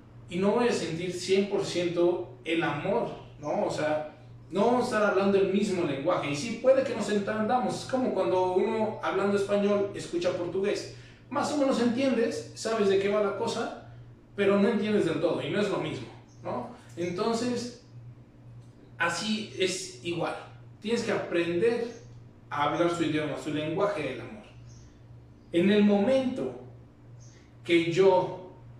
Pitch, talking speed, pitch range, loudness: 180 Hz, 155 wpm, 145-205 Hz, -28 LUFS